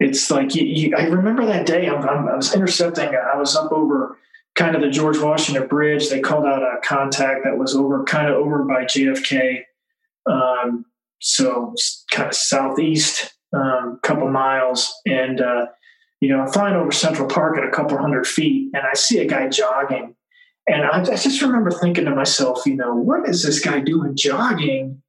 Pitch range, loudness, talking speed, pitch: 135-170 Hz, -18 LUFS, 195 wpm, 145 Hz